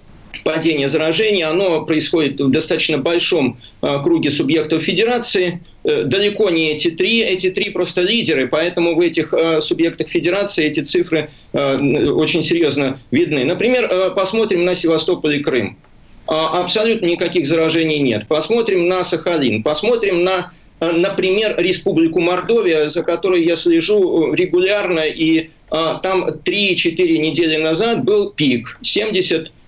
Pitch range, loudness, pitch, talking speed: 160-195 Hz, -16 LUFS, 175 Hz, 135 wpm